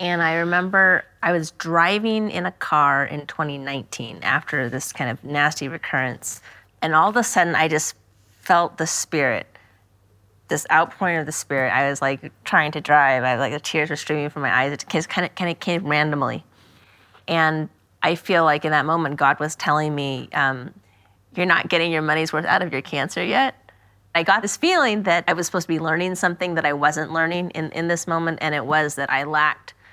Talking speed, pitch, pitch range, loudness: 210 wpm, 155 Hz, 135-170 Hz, -21 LUFS